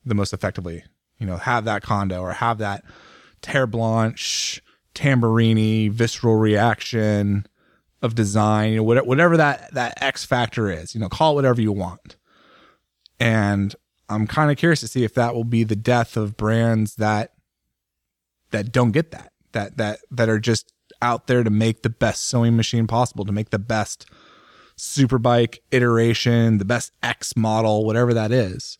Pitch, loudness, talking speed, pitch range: 115 Hz, -20 LUFS, 165 wpm, 105-120 Hz